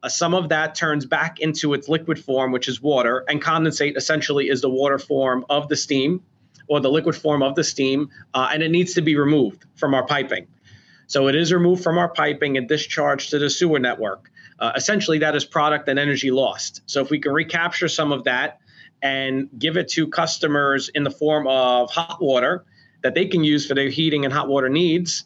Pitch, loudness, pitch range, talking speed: 150 Hz, -20 LUFS, 140-160 Hz, 215 wpm